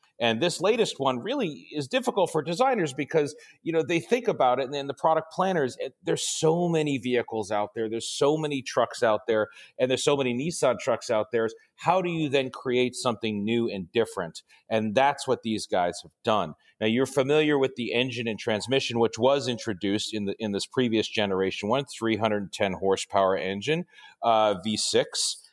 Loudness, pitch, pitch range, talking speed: -26 LUFS, 125 Hz, 110-145 Hz, 190 wpm